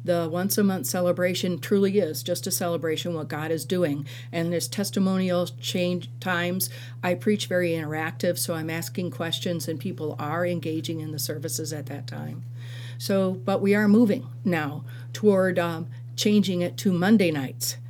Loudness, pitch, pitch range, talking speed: -25 LUFS, 165 Hz, 135-180 Hz, 170 wpm